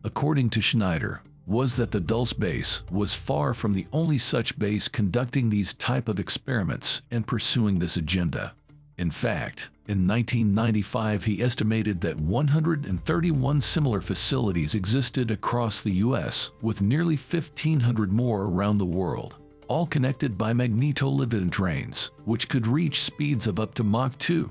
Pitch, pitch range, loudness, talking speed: 115 Hz, 105-135 Hz, -25 LUFS, 145 wpm